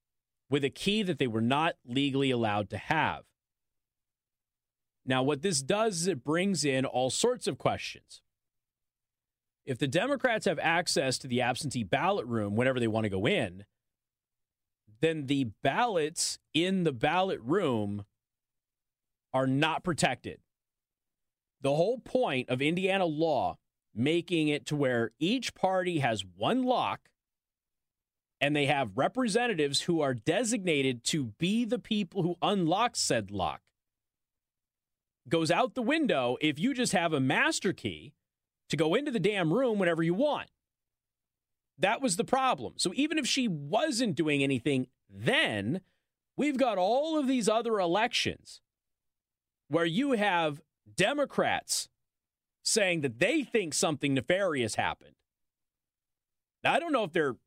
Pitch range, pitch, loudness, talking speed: 130-205 Hz, 160 Hz, -29 LUFS, 140 wpm